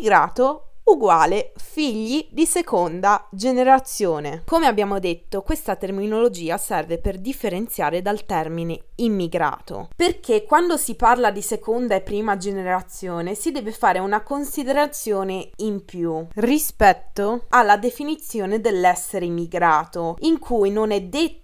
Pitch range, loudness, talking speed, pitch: 185-275 Hz, -21 LUFS, 120 wpm, 210 Hz